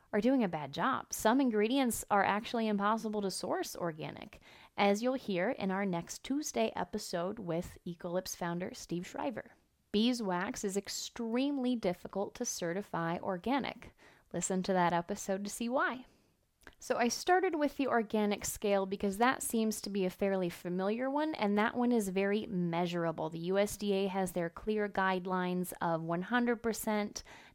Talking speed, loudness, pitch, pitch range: 150 wpm, -34 LUFS, 205 Hz, 185-235 Hz